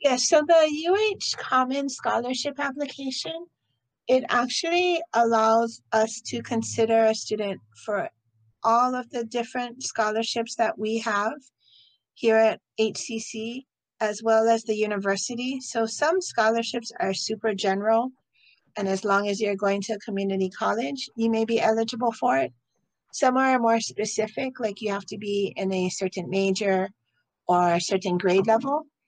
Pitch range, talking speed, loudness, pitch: 200-250 Hz, 150 wpm, -25 LUFS, 225 Hz